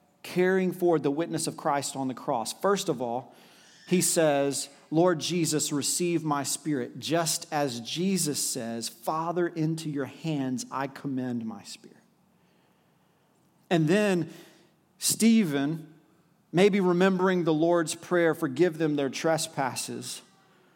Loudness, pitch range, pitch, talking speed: -27 LUFS, 140-175 Hz, 160 Hz, 125 wpm